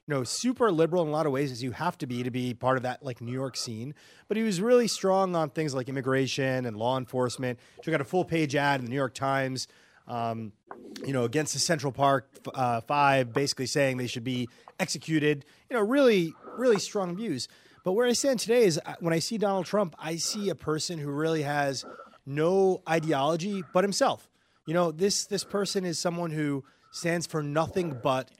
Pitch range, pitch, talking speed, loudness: 130-180 Hz, 155 Hz, 210 wpm, -28 LUFS